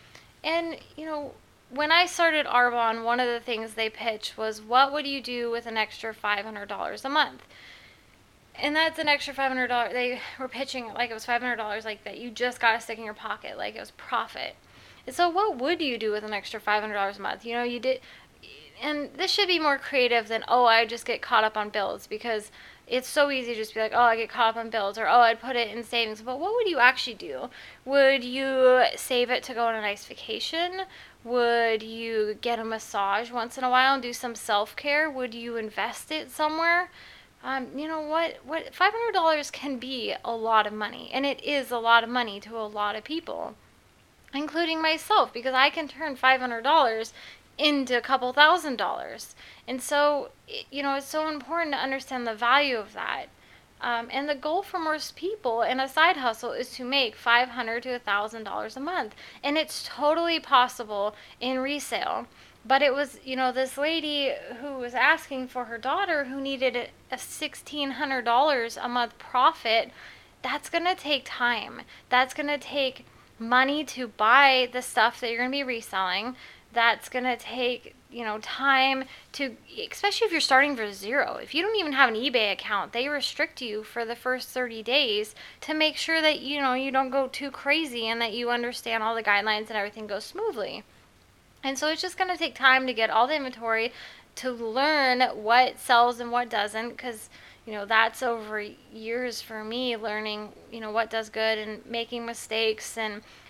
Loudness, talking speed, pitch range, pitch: -26 LUFS, 210 wpm, 230-285 Hz, 250 Hz